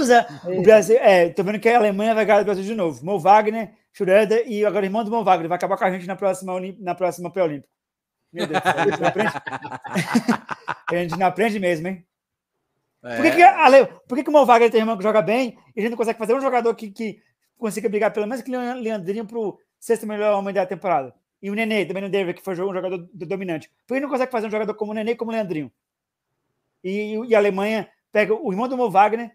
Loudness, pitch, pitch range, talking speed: -20 LUFS, 210 Hz, 190-230 Hz, 235 wpm